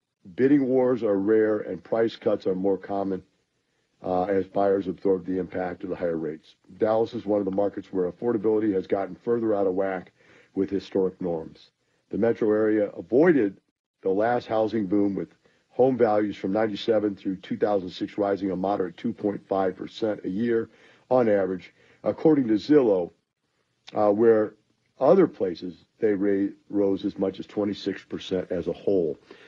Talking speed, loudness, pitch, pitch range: 155 wpm, -25 LUFS, 100 Hz, 95-110 Hz